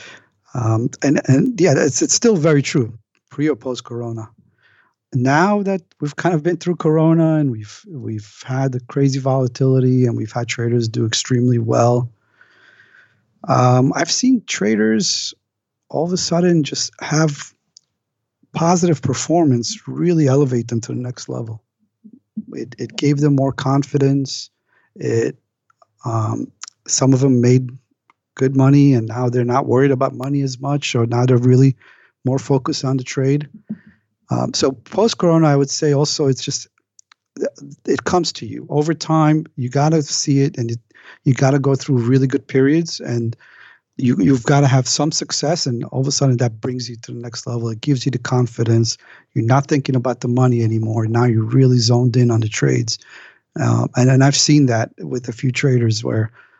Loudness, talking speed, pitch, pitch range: -17 LUFS, 175 wpm, 135 Hz, 120-150 Hz